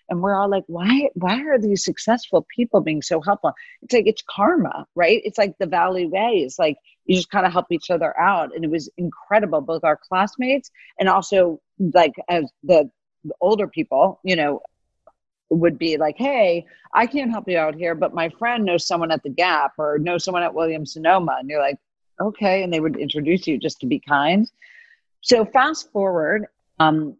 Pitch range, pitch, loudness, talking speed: 165-220 Hz, 185 Hz, -20 LUFS, 200 wpm